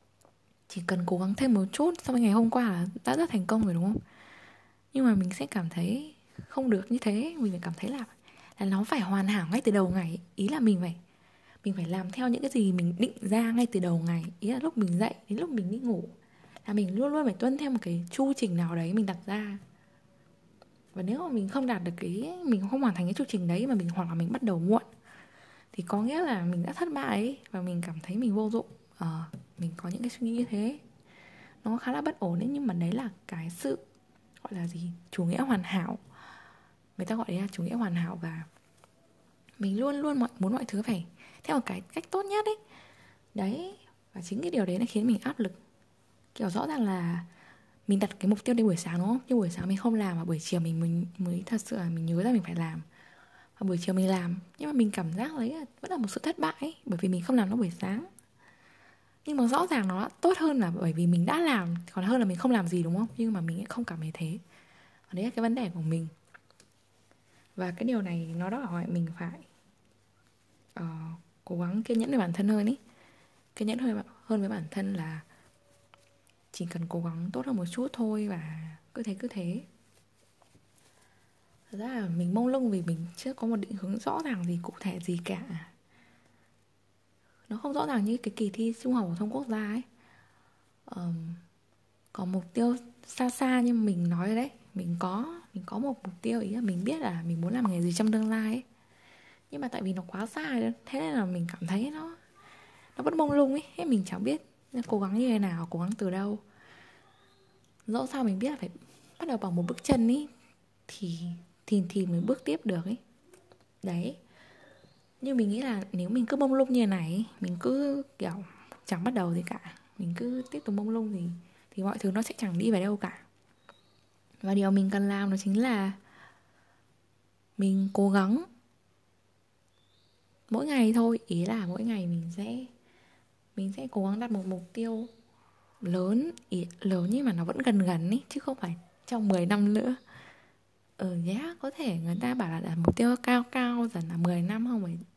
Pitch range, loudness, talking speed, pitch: 175-240 Hz, -31 LUFS, 230 wpm, 200 Hz